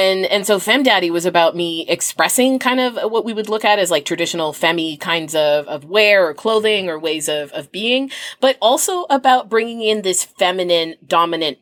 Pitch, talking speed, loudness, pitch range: 185 Hz, 200 wpm, -16 LUFS, 165-225 Hz